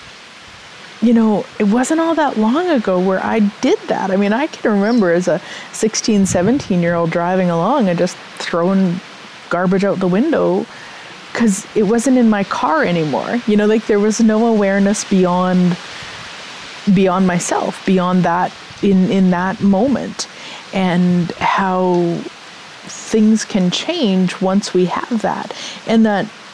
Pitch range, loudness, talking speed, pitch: 180-225 Hz, -15 LUFS, 150 wpm, 195 Hz